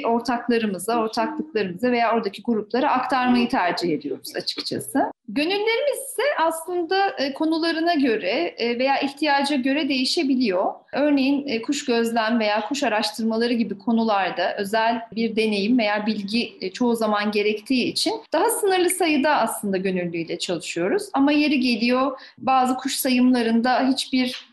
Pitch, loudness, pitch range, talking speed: 245 Hz, -22 LUFS, 220-285 Hz, 115 wpm